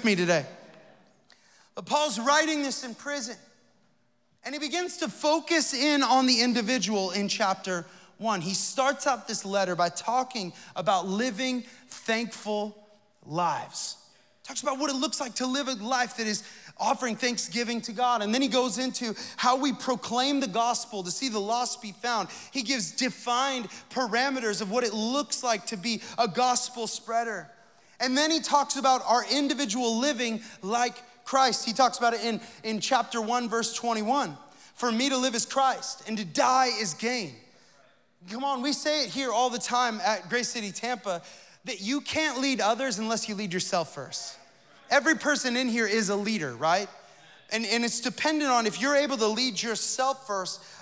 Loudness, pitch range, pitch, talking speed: -27 LUFS, 215-260 Hz, 240 Hz, 180 wpm